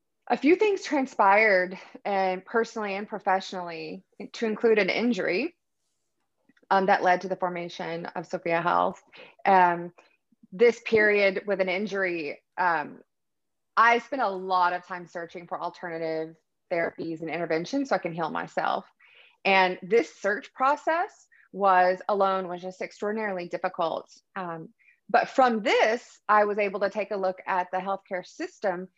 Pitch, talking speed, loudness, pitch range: 195 Hz, 145 wpm, -26 LUFS, 180-225 Hz